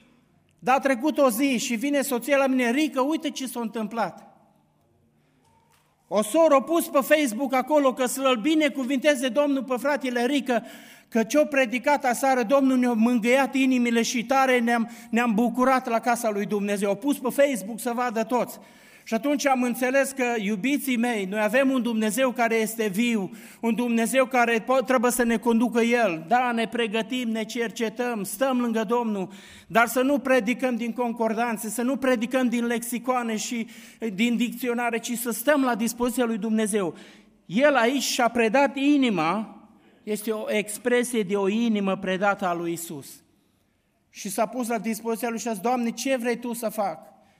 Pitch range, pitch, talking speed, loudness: 225-260 Hz, 240 Hz, 170 wpm, -24 LUFS